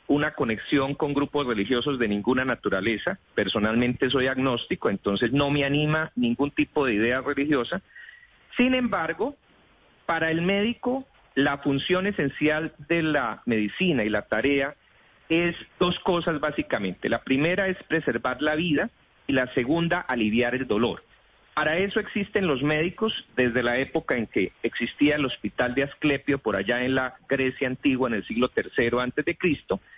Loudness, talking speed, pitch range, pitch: -25 LUFS, 155 wpm, 130-165 Hz, 145 Hz